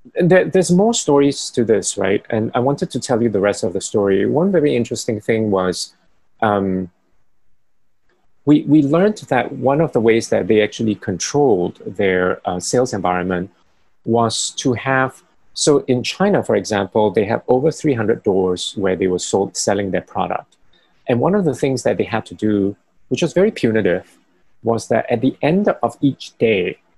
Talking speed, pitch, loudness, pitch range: 180 wpm, 115 Hz, -17 LUFS, 100-145 Hz